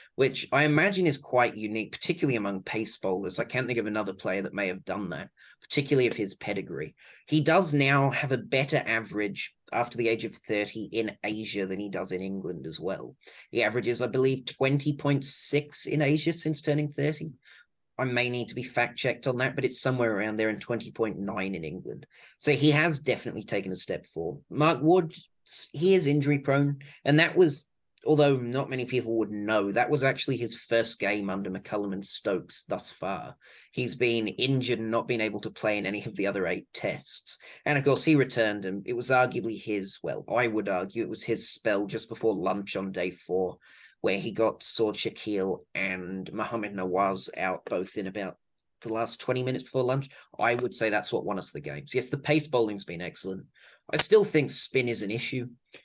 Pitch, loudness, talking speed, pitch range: 120 Hz, -27 LUFS, 205 wpm, 105-140 Hz